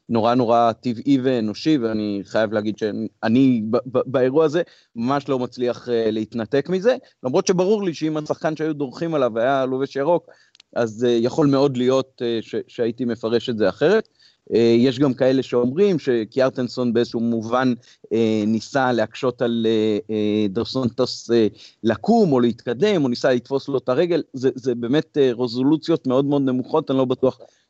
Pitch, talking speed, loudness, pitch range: 125 Hz, 165 wpm, -21 LUFS, 115-140 Hz